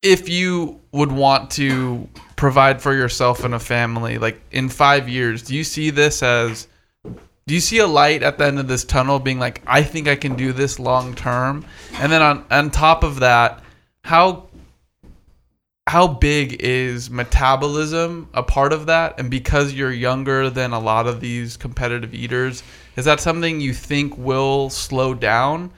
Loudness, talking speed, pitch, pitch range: -18 LUFS, 175 wpm, 135 Hz, 125-145 Hz